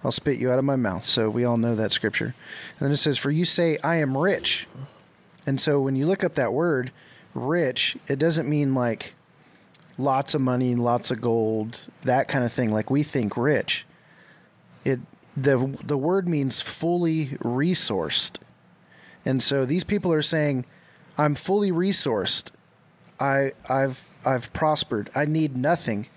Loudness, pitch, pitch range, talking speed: -23 LUFS, 140 Hz, 125-160 Hz, 165 wpm